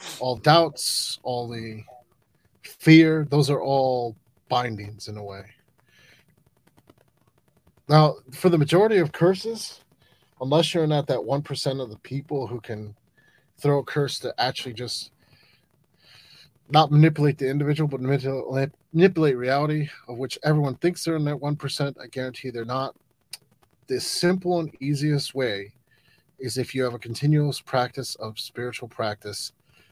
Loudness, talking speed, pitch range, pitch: -24 LUFS, 140 wpm, 125-150 Hz, 135 Hz